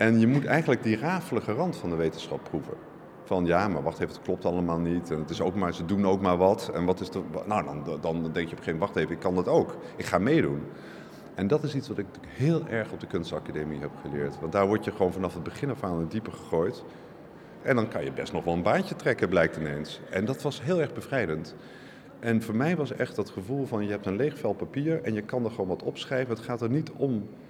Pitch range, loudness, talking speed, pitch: 85-130 Hz, -29 LUFS, 265 wpm, 105 Hz